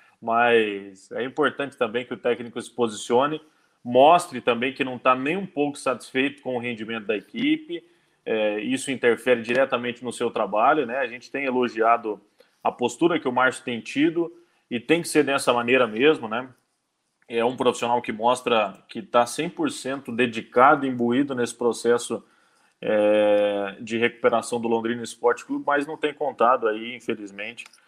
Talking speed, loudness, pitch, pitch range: 160 wpm, -23 LUFS, 120 Hz, 115-140 Hz